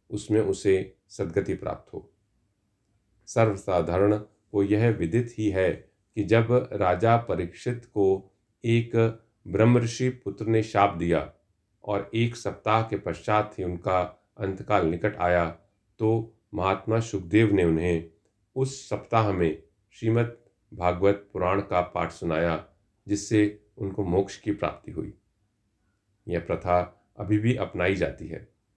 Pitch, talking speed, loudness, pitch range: 100 Hz, 125 wpm, -26 LUFS, 95-110 Hz